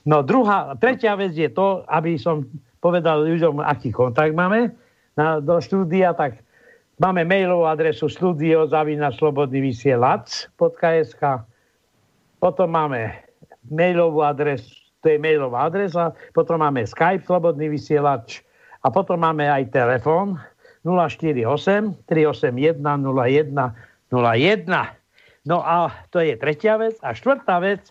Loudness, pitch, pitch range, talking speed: -20 LUFS, 160 Hz, 145-180 Hz, 110 wpm